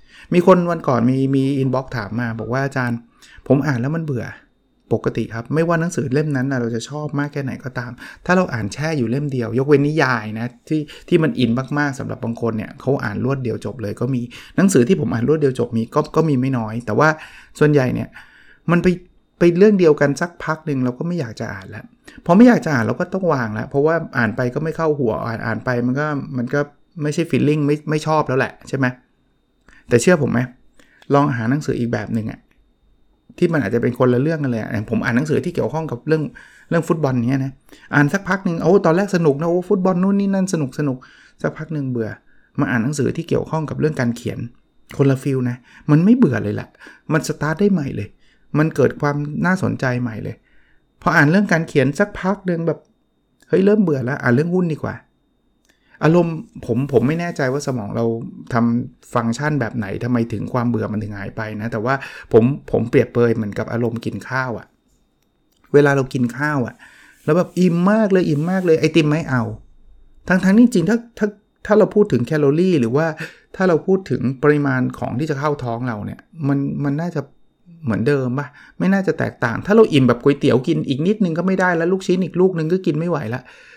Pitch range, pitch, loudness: 120-165 Hz, 140 Hz, -19 LUFS